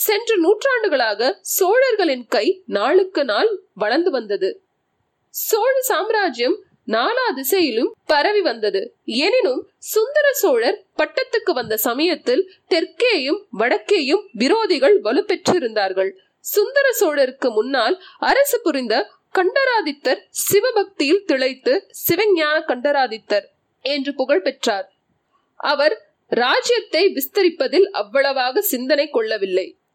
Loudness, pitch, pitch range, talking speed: -19 LUFS, 360 Hz, 270-415 Hz, 85 wpm